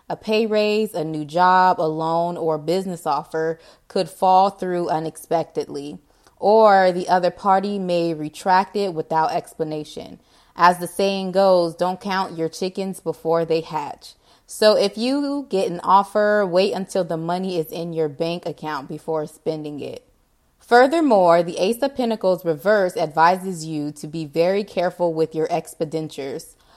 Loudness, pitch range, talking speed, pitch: -20 LUFS, 160-195 Hz, 155 wpm, 175 Hz